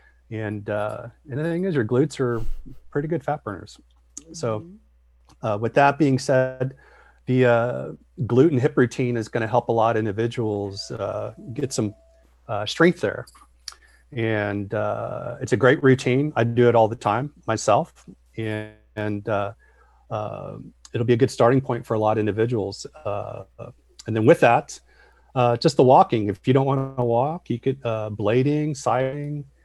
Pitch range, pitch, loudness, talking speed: 110-135 Hz, 120 Hz, -22 LUFS, 175 wpm